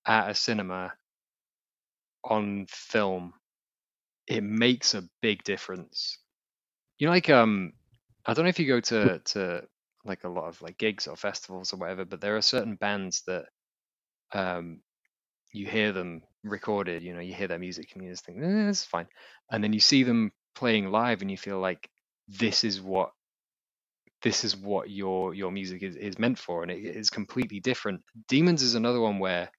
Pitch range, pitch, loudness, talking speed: 95-115 Hz, 105 Hz, -28 LUFS, 185 wpm